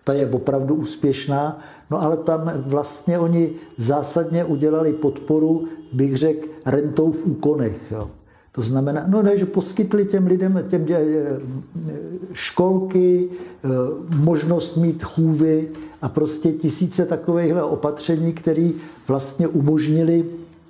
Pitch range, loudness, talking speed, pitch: 150-170 Hz, -20 LUFS, 115 wpm, 160 Hz